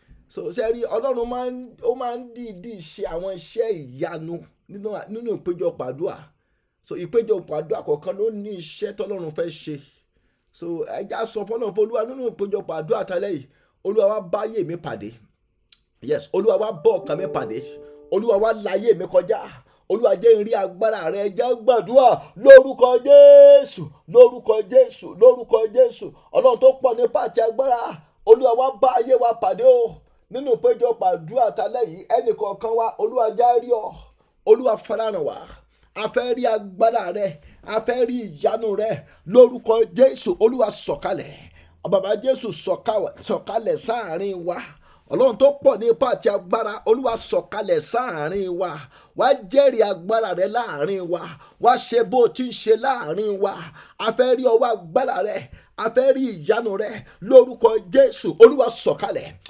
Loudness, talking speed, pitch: -19 LUFS, 120 wpm, 240 Hz